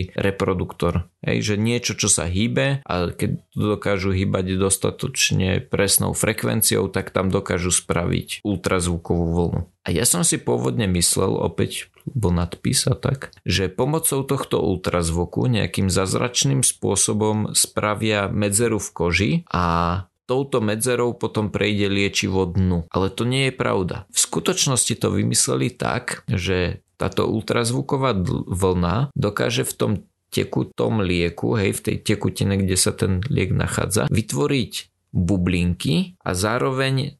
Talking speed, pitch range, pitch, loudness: 125 wpm, 90-120 Hz, 100 Hz, -21 LUFS